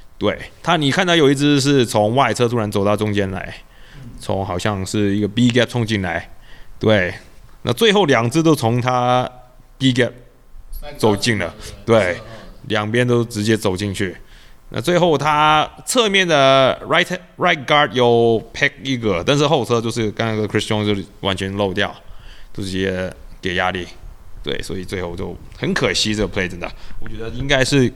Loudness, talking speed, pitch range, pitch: -17 LUFS, 295 characters per minute, 100-130 Hz, 110 Hz